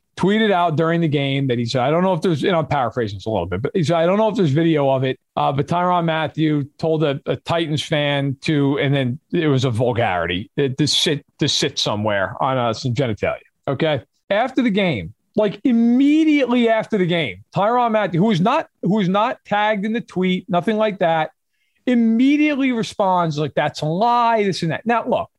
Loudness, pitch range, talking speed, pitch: -19 LUFS, 145-215 Hz, 215 wpm, 170 Hz